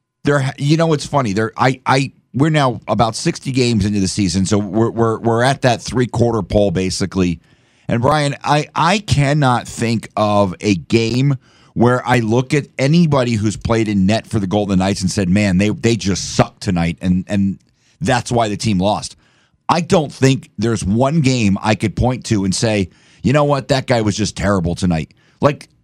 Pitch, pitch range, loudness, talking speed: 115 Hz, 100-135 Hz, -16 LUFS, 195 wpm